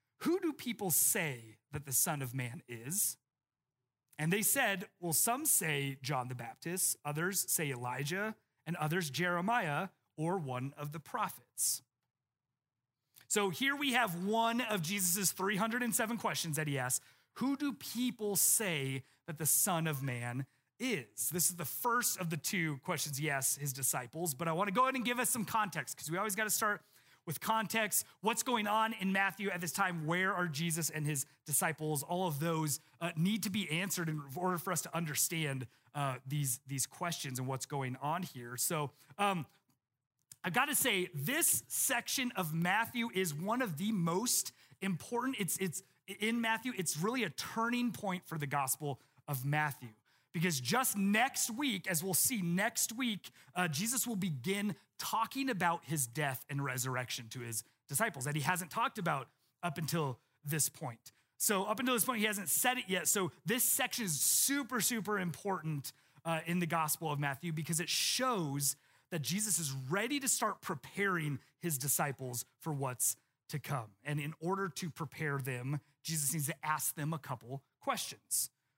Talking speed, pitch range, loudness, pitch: 175 wpm, 140-200 Hz, -35 LUFS, 165 Hz